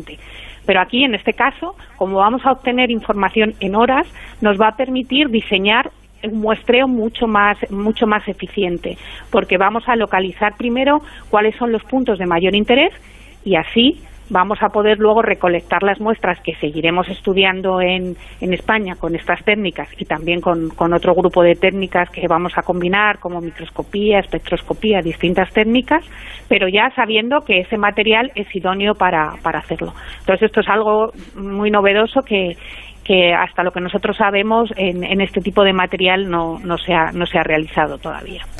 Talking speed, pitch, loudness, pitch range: 170 wpm, 195 Hz, -16 LUFS, 175-220 Hz